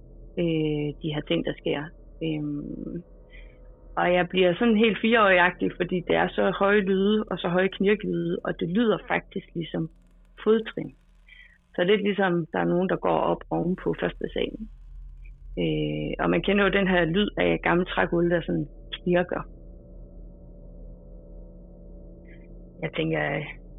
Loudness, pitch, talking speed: -25 LUFS, 170 Hz, 150 wpm